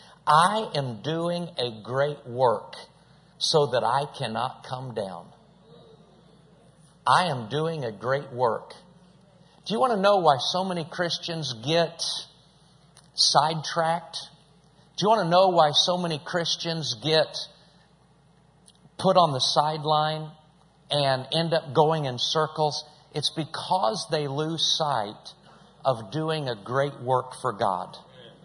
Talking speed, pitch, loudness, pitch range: 130 wpm, 155 Hz, -25 LUFS, 140-170 Hz